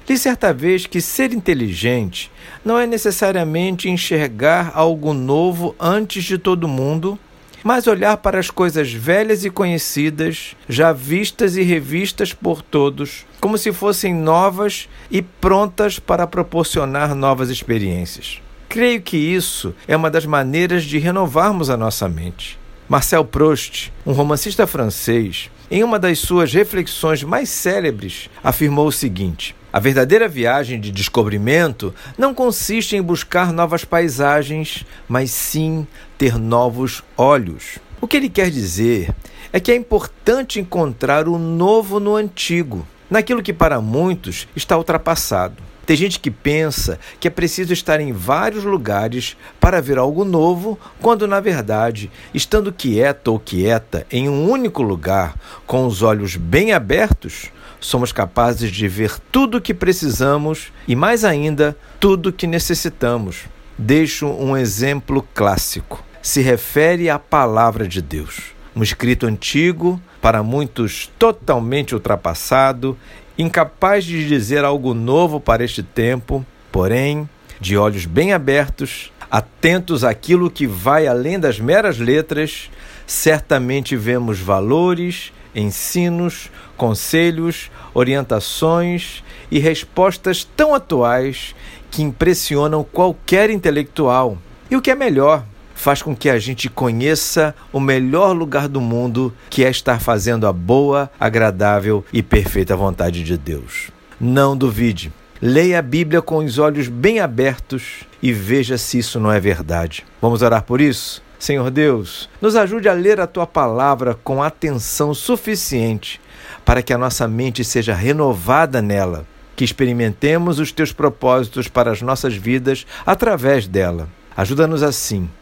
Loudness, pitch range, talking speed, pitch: -17 LUFS, 120-175 Hz, 135 wpm, 145 Hz